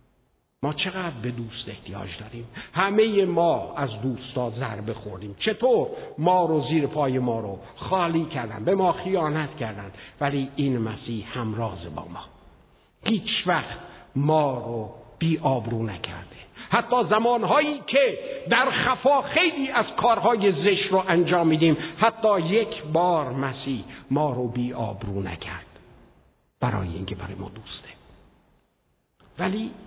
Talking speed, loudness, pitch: 125 wpm, -24 LUFS, 145 Hz